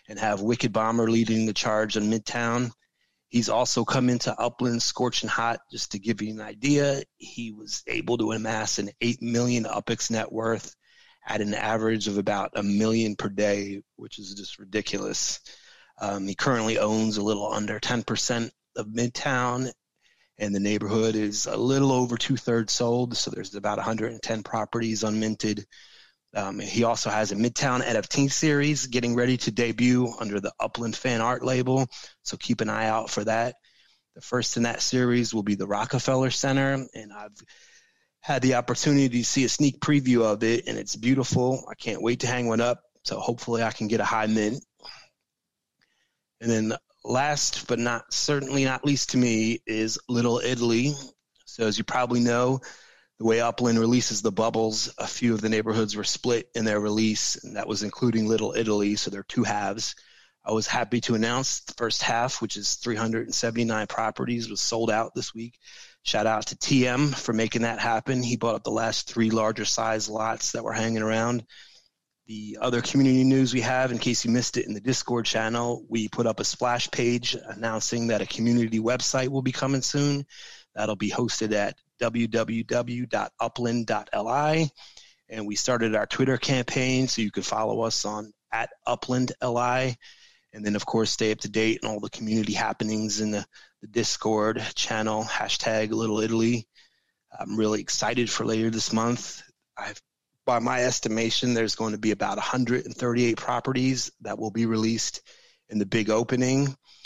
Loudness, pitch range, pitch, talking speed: -26 LUFS, 110-125 Hz, 115 Hz, 175 wpm